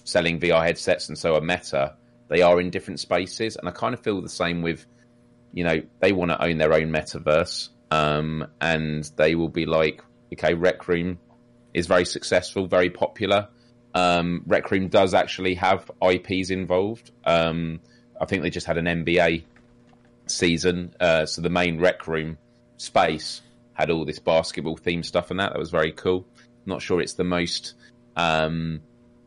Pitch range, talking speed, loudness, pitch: 80-95 Hz, 175 wpm, -23 LUFS, 85 Hz